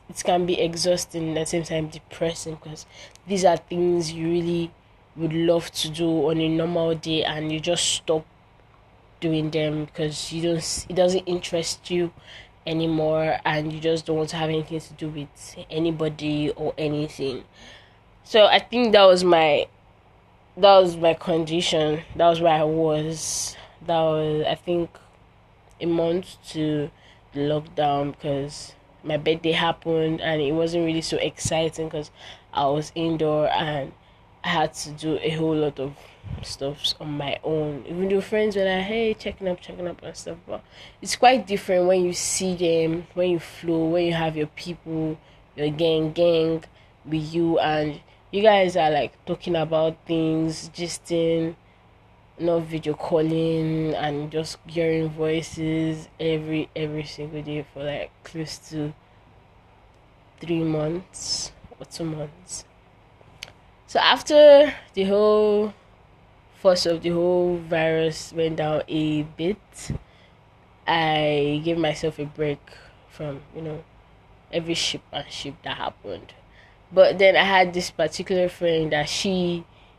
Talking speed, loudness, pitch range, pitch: 150 wpm, -23 LUFS, 150-170 Hz, 160 Hz